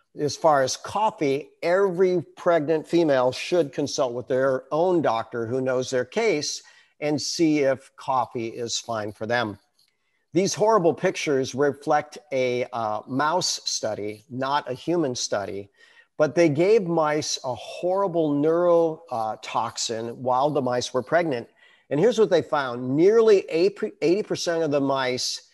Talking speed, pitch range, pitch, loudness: 140 wpm, 125-175 Hz, 150 Hz, -24 LUFS